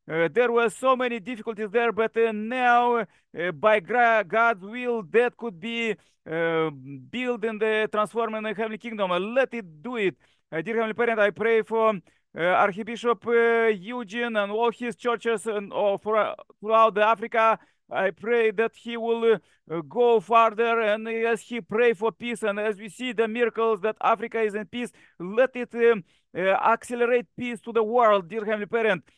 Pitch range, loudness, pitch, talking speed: 210-235 Hz, -24 LUFS, 225 Hz, 180 wpm